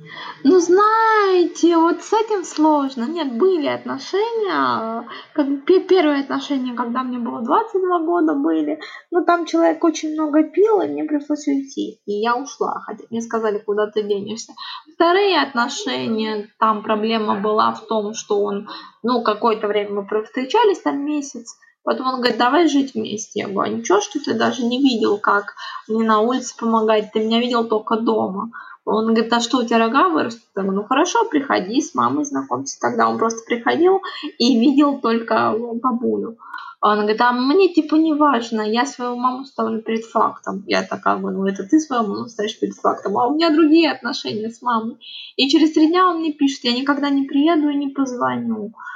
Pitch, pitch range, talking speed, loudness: 260 Hz, 225-320 Hz, 180 wpm, -19 LUFS